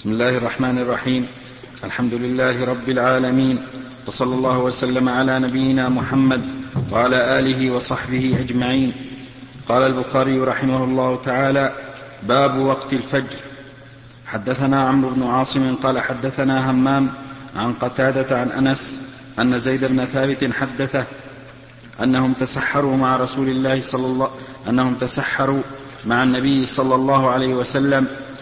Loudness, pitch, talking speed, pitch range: -19 LUFS, 130 Hz, 120 wpm, 125-135 Hz